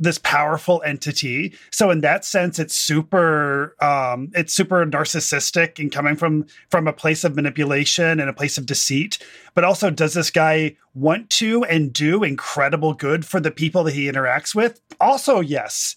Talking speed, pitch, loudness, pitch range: 175 wpm, 155 Hz, -19 LUFS, 145-175 Hz